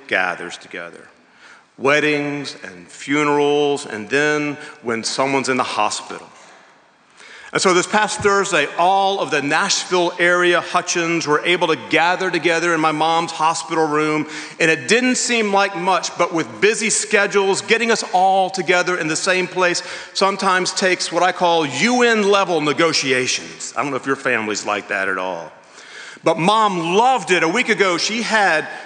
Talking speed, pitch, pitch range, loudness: 160 wpm, 175 Hz, 150-195 Hz, -17 LUFS